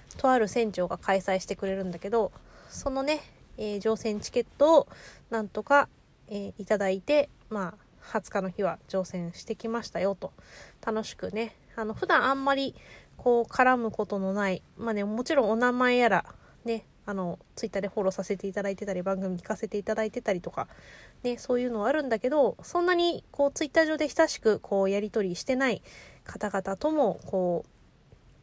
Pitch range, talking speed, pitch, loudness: 195-255 Hz, 365 characters per minute, 220 Hz, -28 LUFS